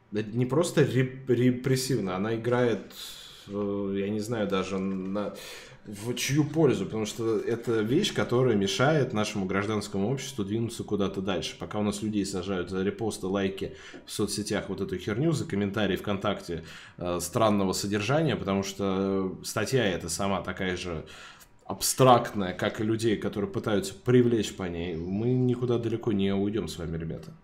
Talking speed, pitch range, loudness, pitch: 145 wpm, 95-120 Hz, -28 LUFS, 105 Hz